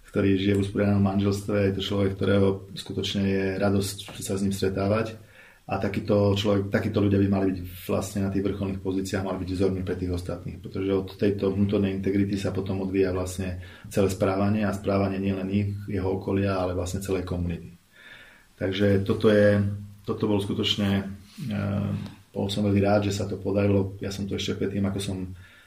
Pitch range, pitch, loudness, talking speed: 95-100 Hz, 100 Hz, -26 LUFS, 180 wpm